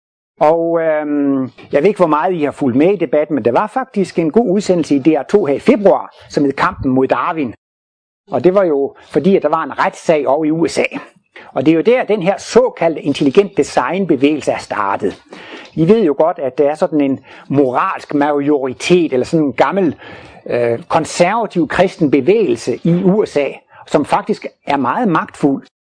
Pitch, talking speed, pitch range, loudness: 160 Hz, 185 wpm, 145-190 Hz, -14 LUFS